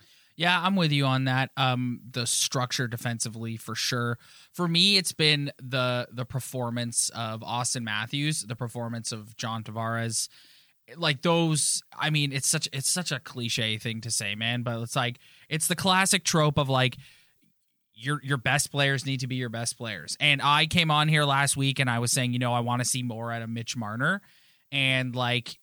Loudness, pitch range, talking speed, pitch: -26 LUFS, 120-145 Hz, 195 wpm, 130 Hz